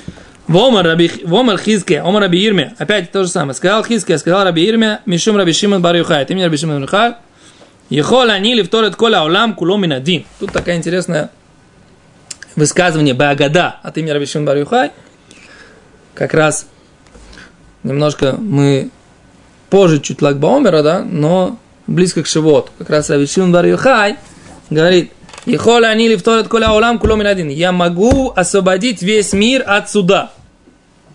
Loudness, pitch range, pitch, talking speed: -12 LUFS, 155-210 Hz, 180 Hz, 140 wpm